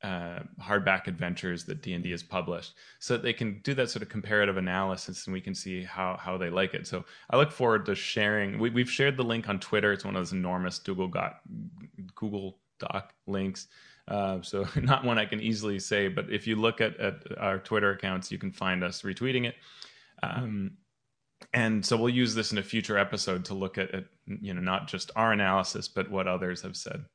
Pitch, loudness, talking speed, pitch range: 100 Hz, -30 LUFS, 220 wpm, 95-110 Hz